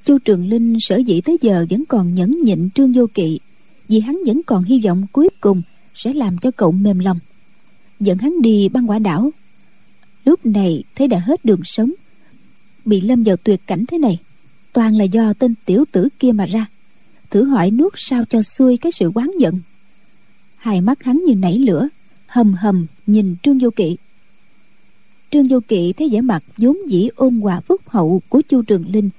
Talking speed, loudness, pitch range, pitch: 195 wpm, -15 LUFS, 195-260 Hz, 220 Hz